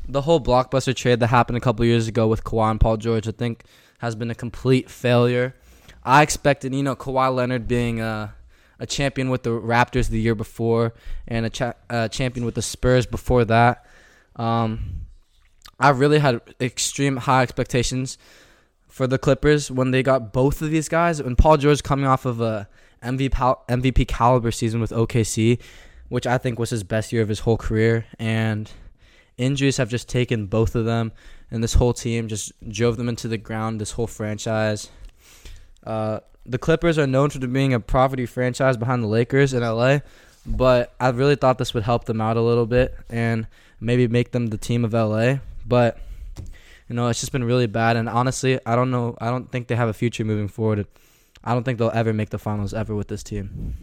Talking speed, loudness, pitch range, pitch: 200 wpm, -21 LUFS, 110-130 Hz, 120 Hz